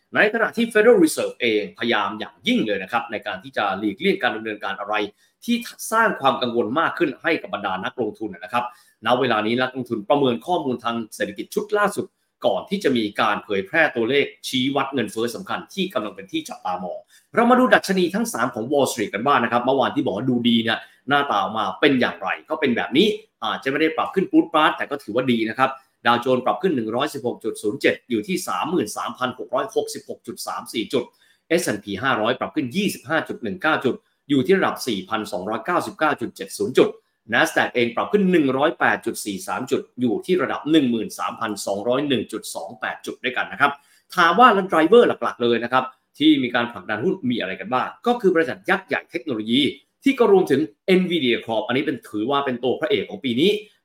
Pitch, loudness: 140 Hz, -21 LUFS